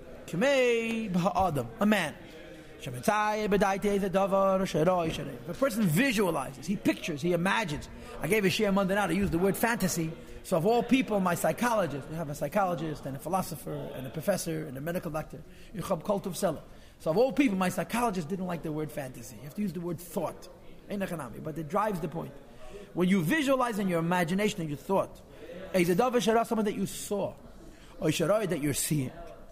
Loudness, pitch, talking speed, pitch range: -29 LUFS, 185 Hz, 165 wpm, 160-205 Hz